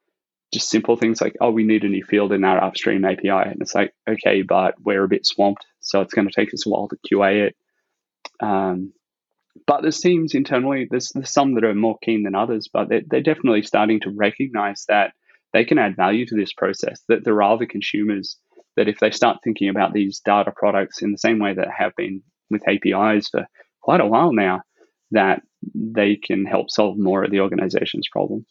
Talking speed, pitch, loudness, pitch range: 215 wpm, 105 Hz, -20 LUFS, 100-115 Hz